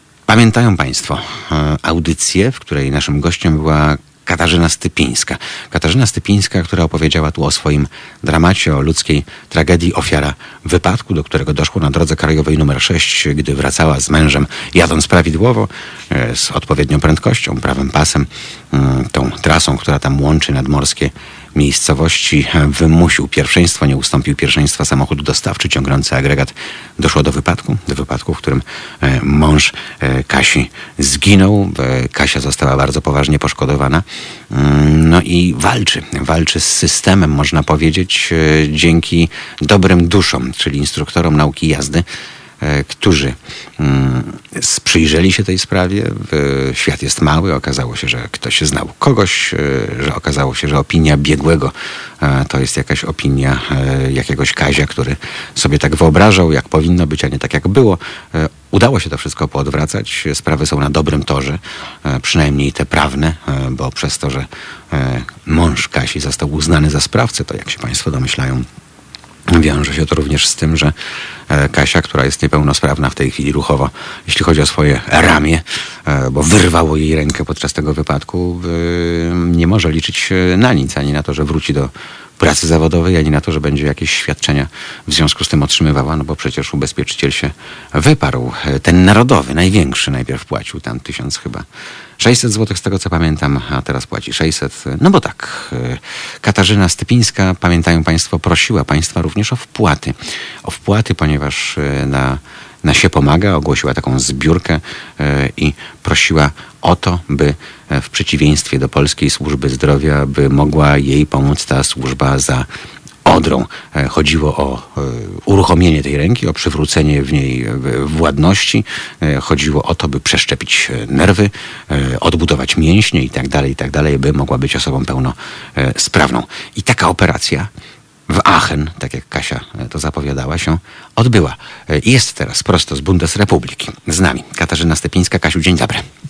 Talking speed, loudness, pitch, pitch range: 140 wpm, -13 LUFS, 75 Hz, 70-85 Hz